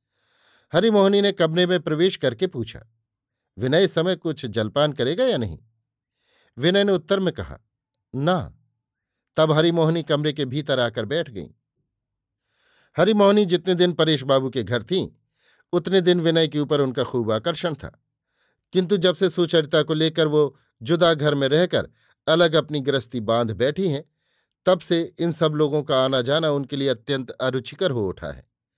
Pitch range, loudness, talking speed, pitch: 130-175 Hz, -21 LUFS, 160 wpm, 150 Hz